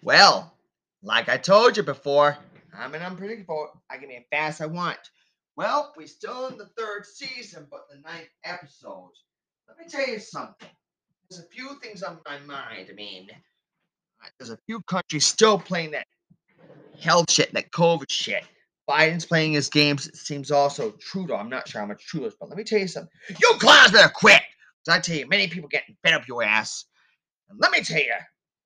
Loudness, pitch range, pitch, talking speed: -20 LUFS, 150-205 Hz, 170 Hz, 205 wpm